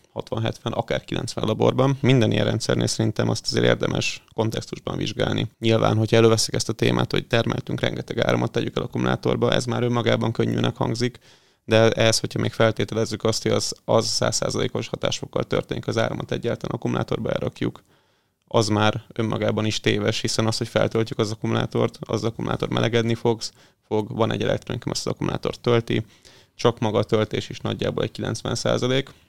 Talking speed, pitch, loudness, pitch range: 160 wpm, 115 Hz, -23 LUFS, 110-120 Hz